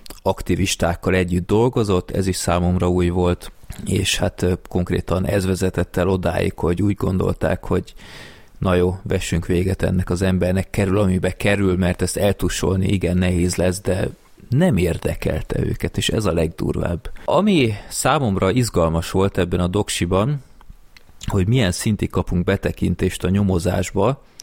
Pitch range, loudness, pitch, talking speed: 90-100 Hz, -20 LUFS, 95 Hz, 140 wpm